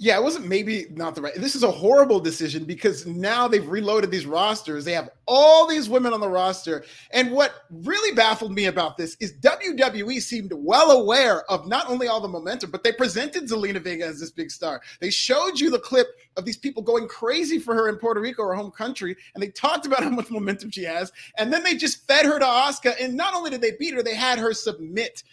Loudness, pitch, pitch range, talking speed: -22 LUFS, 225 Hz, 190-265 Hz, 235 wpm